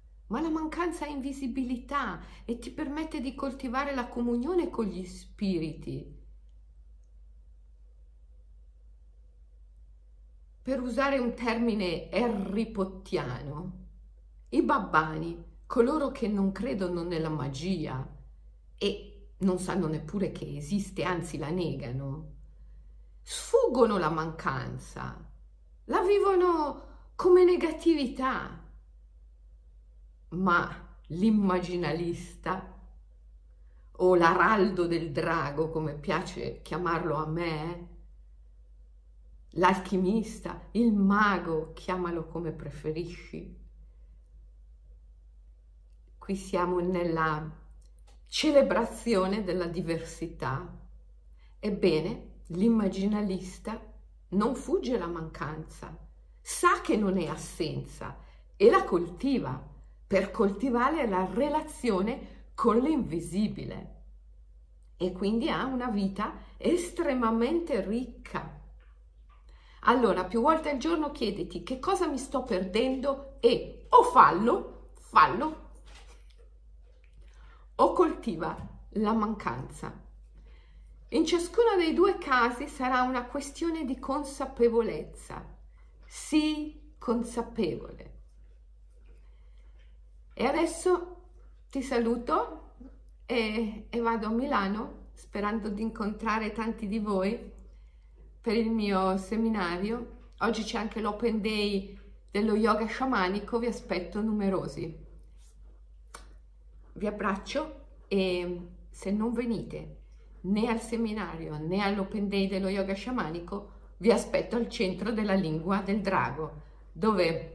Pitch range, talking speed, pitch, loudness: 150-235 Hz, 90 wpm, 190 Hz, -29 LUFS